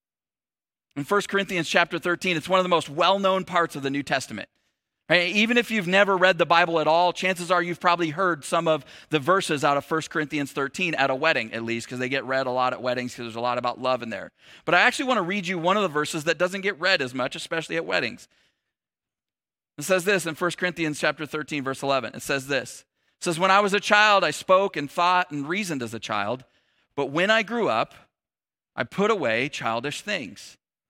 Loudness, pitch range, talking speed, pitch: -23 LUFS, 140-185 Hz, 235 wpm, 165 Hz